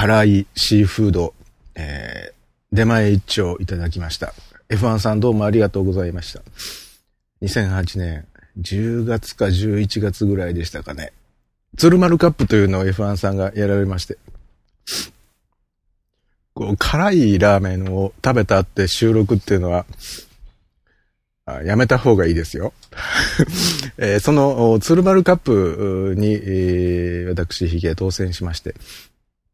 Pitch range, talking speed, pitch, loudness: 90-110 Hz, 250 characters per minute, 100 Hz, -18 LUFS